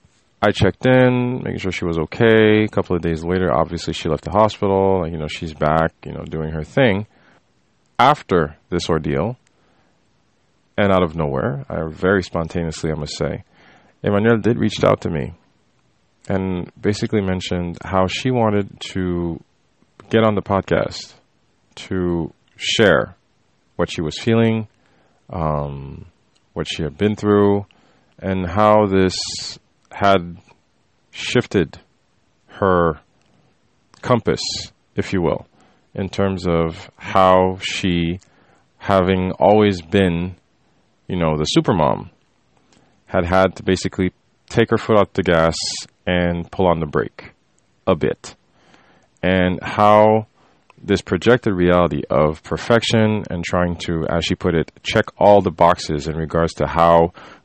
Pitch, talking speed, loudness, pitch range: 95 Hz, 135 wpm, -18 LUFS, 85-105 Hz